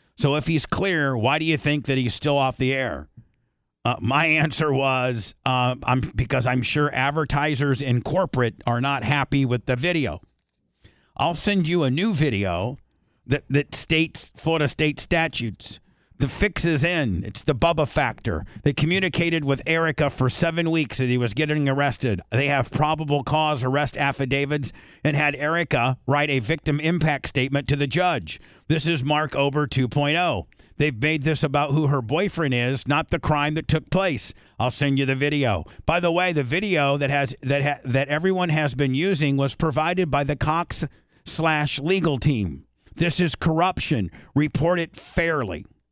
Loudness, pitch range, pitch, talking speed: -23 LUFS, 130-160 Hz, 145 Hz, 175 wpm